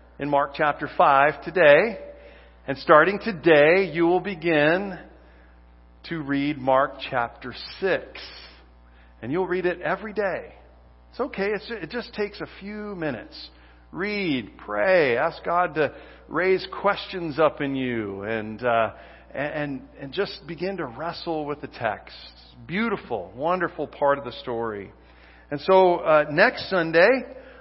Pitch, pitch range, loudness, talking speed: 145 Hz, 110-180 Hz, -23 LUFS, 135 wpm